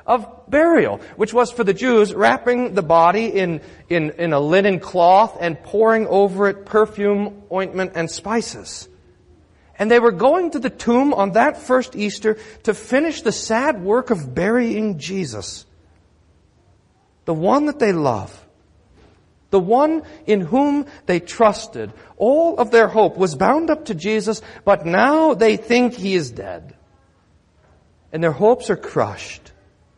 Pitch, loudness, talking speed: 200 Hz, -18 LUFS, 150 wpm